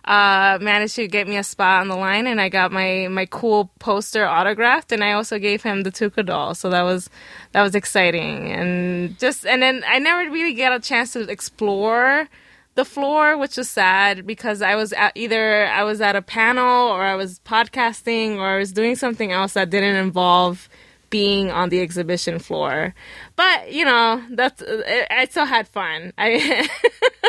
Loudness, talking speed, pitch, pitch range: -18 LUFS, 190 wpm, 210 Hz, 190-245 Hz